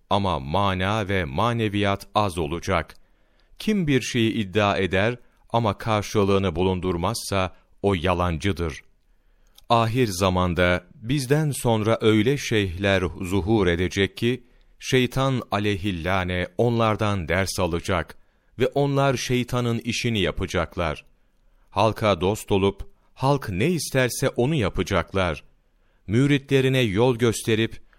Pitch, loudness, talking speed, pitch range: 100 Hz, -23 LUFS, 100 wpm, 95-120 Hz